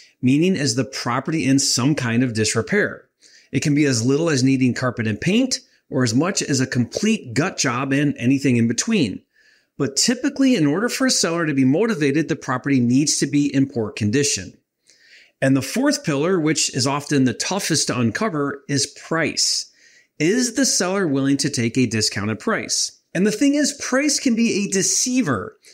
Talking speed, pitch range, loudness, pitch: 185 wpm, 130-200 Hz, -19 LUFS, 145 Hz